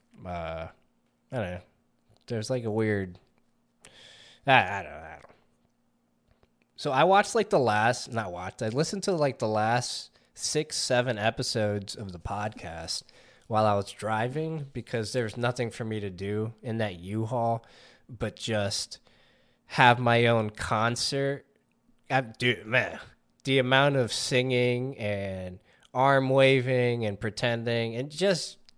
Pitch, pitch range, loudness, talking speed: 115 Hz, 105-130 Hz, -27 LUFS, 140 wpm